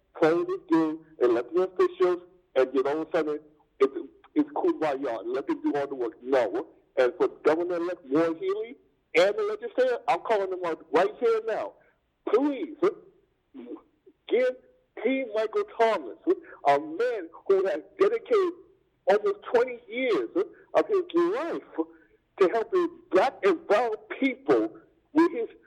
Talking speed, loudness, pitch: 160 wpm, -27 LUFS, 360 Hz